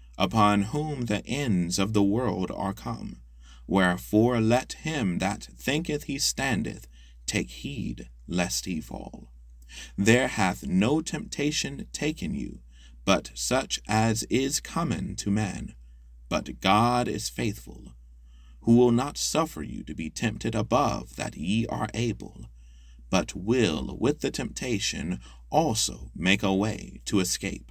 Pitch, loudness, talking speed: 95 Hz, -27 LUFS, 135 wpm